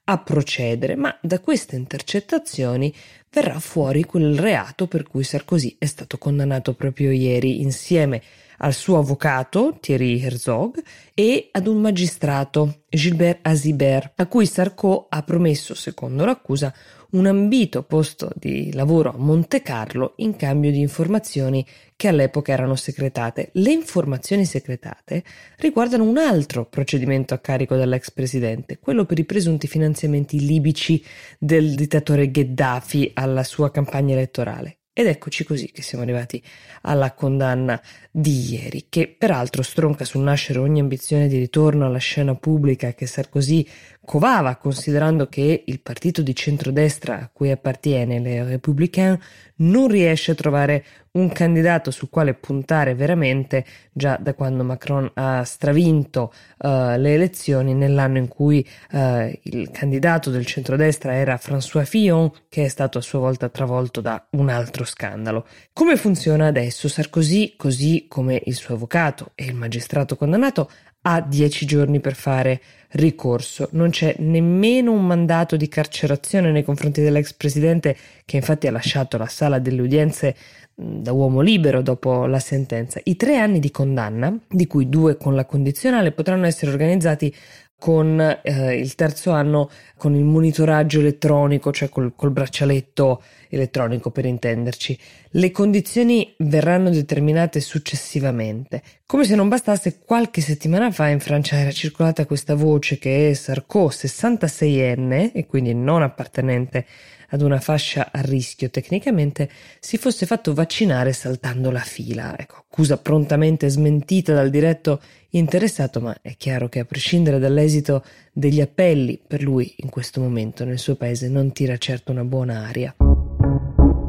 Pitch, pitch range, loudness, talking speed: 145 Hz, 130-160 Hz, -20 LUFS, 145 wpm